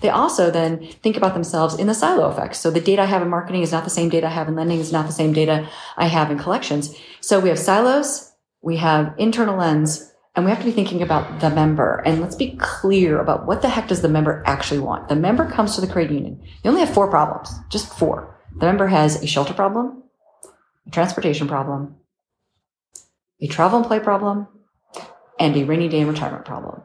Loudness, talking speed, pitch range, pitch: -19 LUFS, 225 wpm, 155-200 Hz, 170 Hz